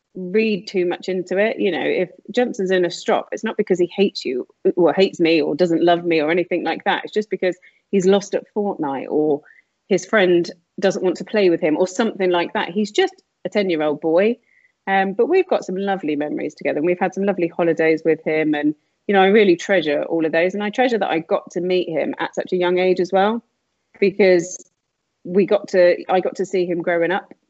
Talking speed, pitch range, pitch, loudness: 235 wpm, 175-205 Hz, 185 Hz, -19 LUFS